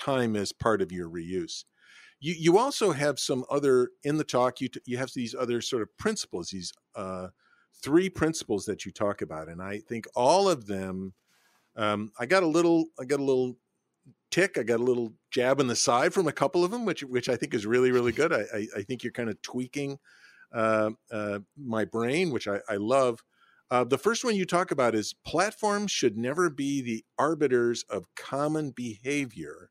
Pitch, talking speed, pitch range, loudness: 125 Hz, 205 wpm, 110-150 Hz, -28 LUFS